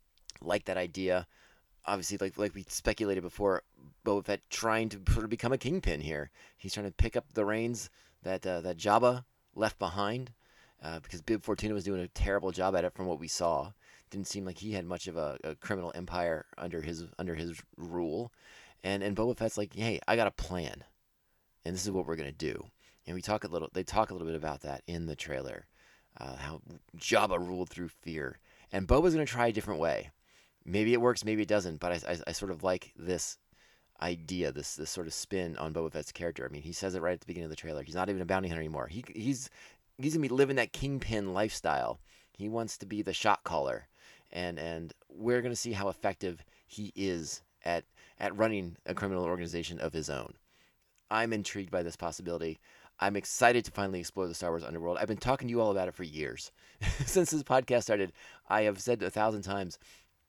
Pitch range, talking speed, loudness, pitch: 85-110 Hz, 220 wpm, -34 LUFS, 95 Hz